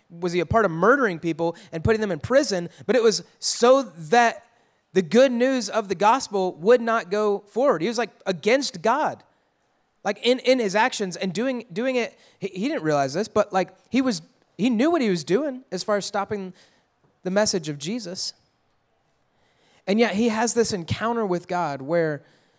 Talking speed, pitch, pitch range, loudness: 190 wpm, 210 Hz, 180-240 Hz, -23 LUFS